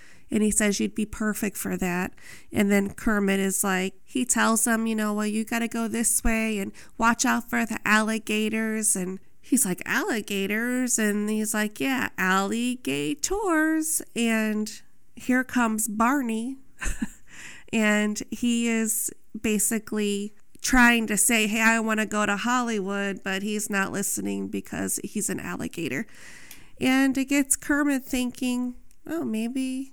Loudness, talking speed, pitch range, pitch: -25 LUFS, 145 wpm, 210-245 Hz, 220 Hz